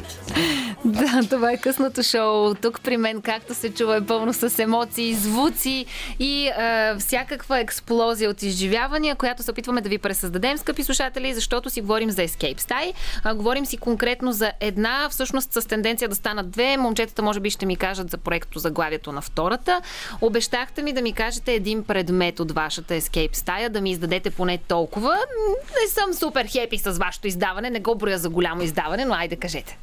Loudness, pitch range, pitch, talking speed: -23 LUFS, 200-255 Hz, 230 Hz, 185 wpm